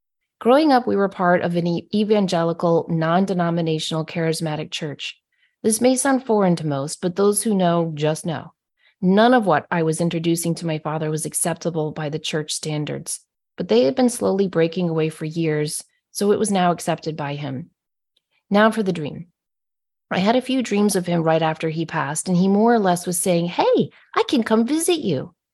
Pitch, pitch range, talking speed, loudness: 170 Hz, 160-205 Hz, 195 wpm, -20 LUFS